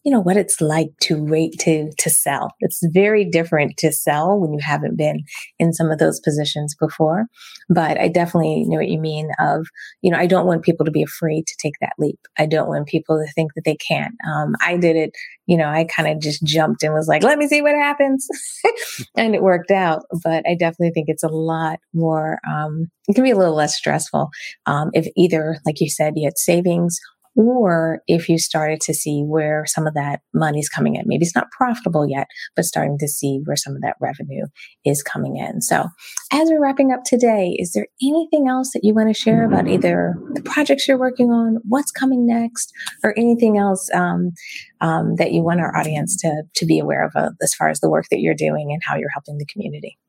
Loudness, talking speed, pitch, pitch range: -18 LUFS, 225 wpm, 165 Hz, 155-210 Hz